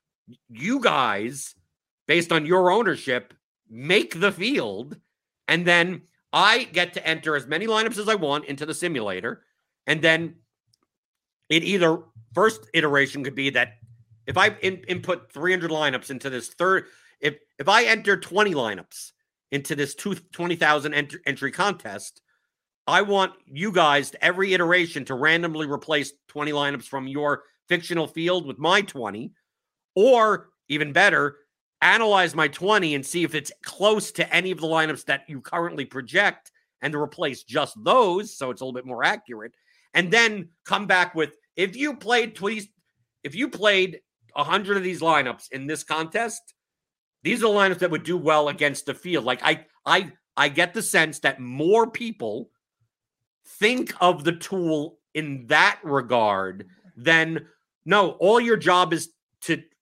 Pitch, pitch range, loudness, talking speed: 165 Hz, 145-190 Hz, -22 LUFS, 160 wpm